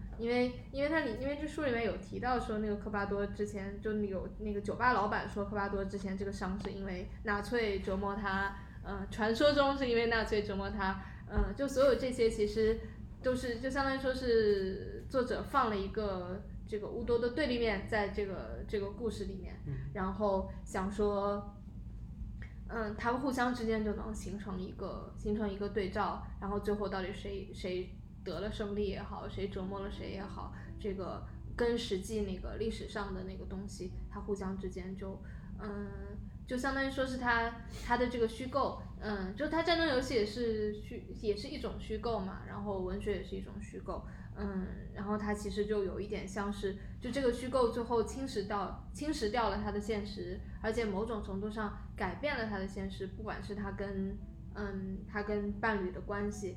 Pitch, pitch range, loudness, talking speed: 210 Hz, 200-235 Hz, -36 LUFS, 280 characters per minute